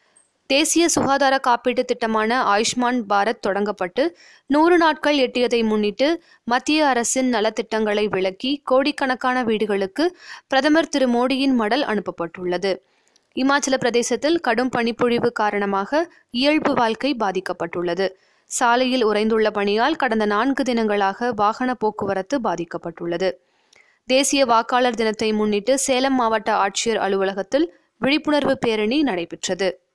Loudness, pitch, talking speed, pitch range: -20 LUFS, 240 Hz, 100 wpm, 210-275 Hz